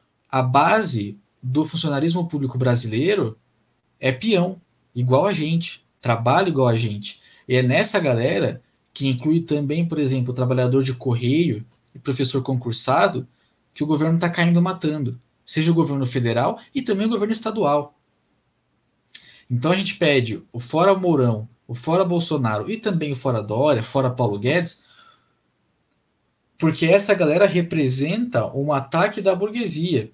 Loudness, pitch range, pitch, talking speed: -21 LUFS, 125-175 Hz, 145 Hz, 145 wpm